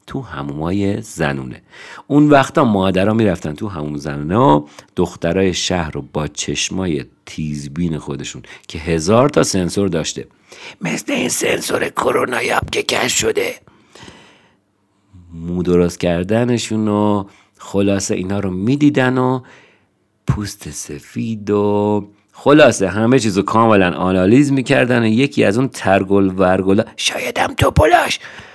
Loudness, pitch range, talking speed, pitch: -16 LUFS, 85-110 Hz, 120 wpm, 100 Hz